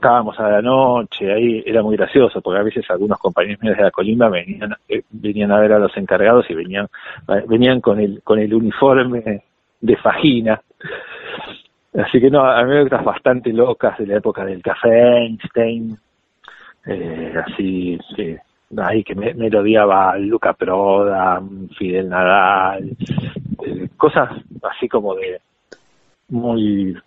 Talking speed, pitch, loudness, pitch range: 145 wpm, 110 Hz, -16 LUFS, 100-120 Hz